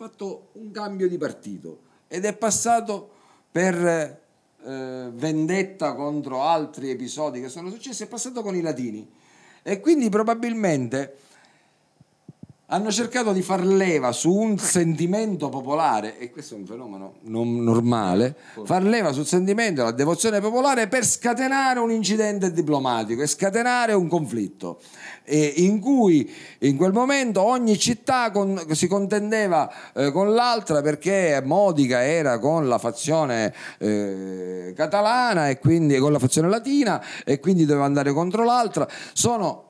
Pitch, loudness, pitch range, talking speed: 175 Hz, -22 LUFS, 140-215 Hz, 140 wpm